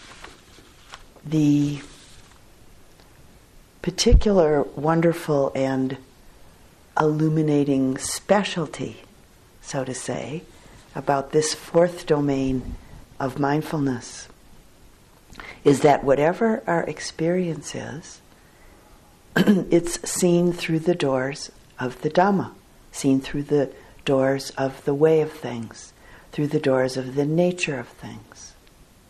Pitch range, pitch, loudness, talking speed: 135-165 Hz, 145 Hz, -22 LUFS, 95 wpm